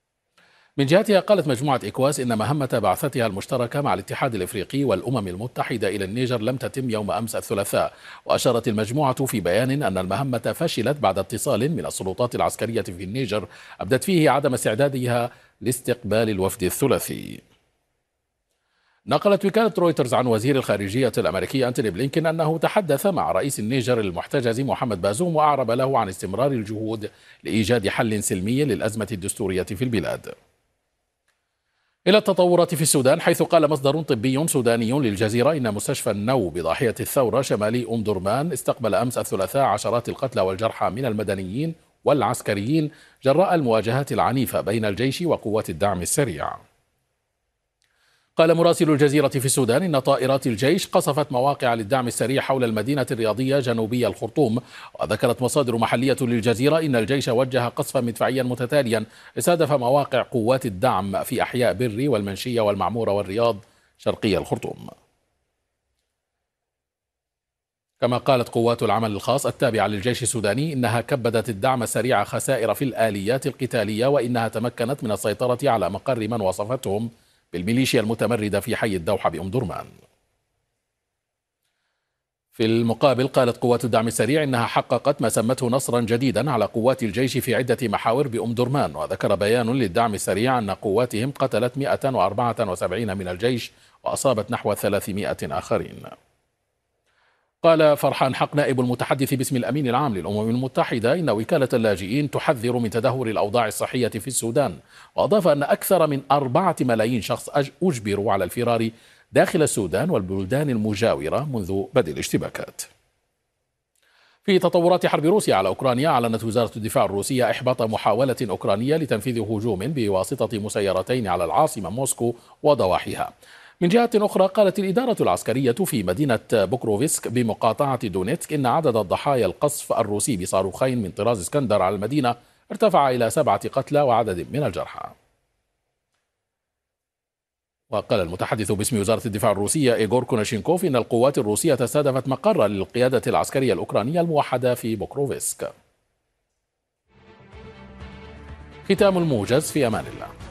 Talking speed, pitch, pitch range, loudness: 130 wpm, 125 Hz, 110-140 Hz, -22 LUFS